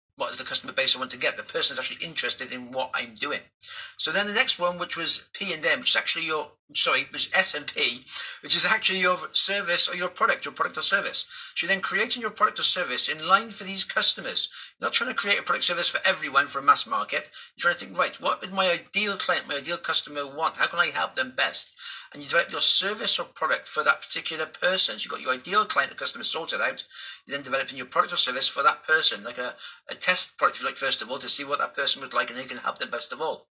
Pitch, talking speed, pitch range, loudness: 185 Hz, 270 wpm, 155-220 Hz, -24 LUFS